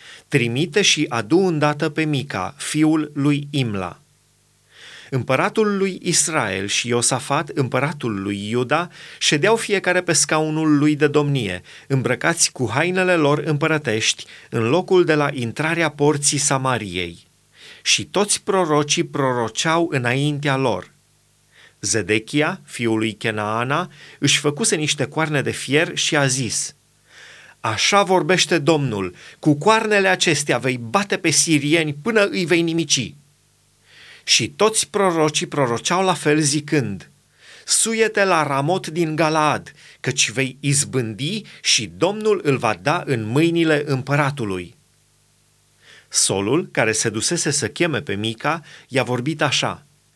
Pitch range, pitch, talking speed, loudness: 125-165 Hz, 150 Hz, 125 wpm, -19 LUFS